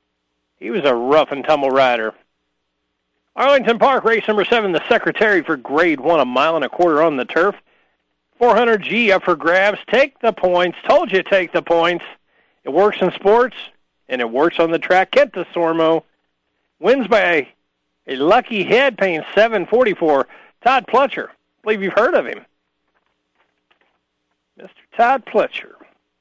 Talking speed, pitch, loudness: 160 wpm, 175 Hz, -16 LUFS